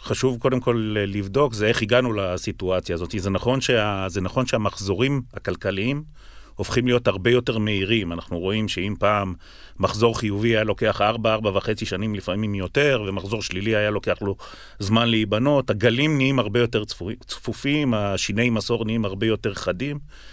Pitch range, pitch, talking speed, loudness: 100-120 Hz, 110 Hz, 150 wpm, -23 LUFS